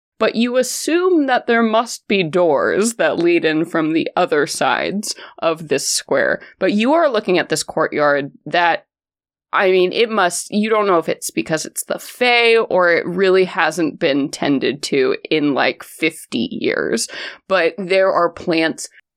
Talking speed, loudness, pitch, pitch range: 170 wpm, -17 LUFS, 190 Hz, 165-235 Hz